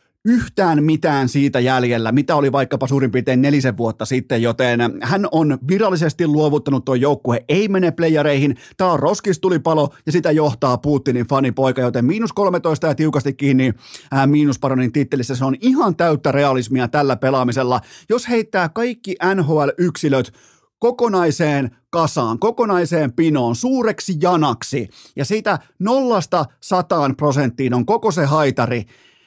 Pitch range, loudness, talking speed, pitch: 130-180 Hz, -17 LUFS, 135 wpm, 145 Hz